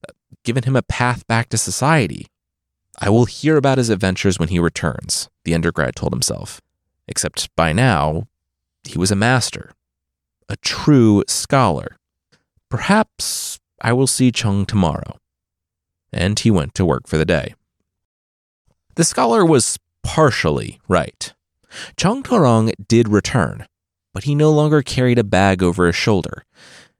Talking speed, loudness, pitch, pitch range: 140 wpm, -17 LUFS, 100 Hz, 85-125 Hz